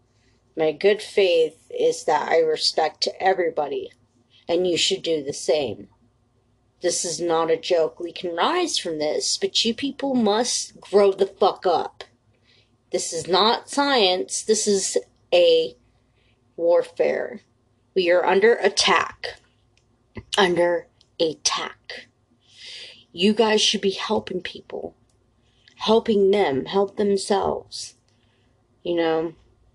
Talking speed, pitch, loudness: 115 wpm, 175 Hz, -21 LUFS